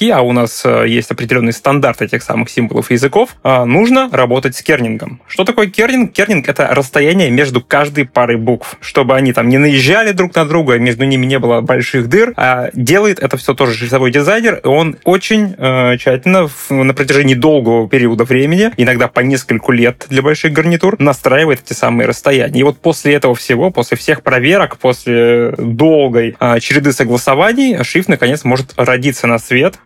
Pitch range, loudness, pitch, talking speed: 125-155 Hz, -11 LUFS, 135 Hz, 175 wpm